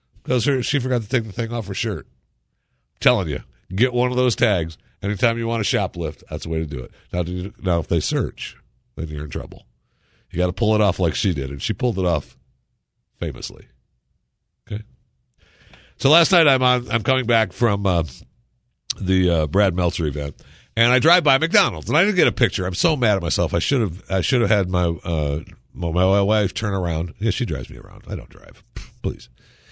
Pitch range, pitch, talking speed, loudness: 85-120 Hz, 100 Hz, 220 wpm, -21 LUFS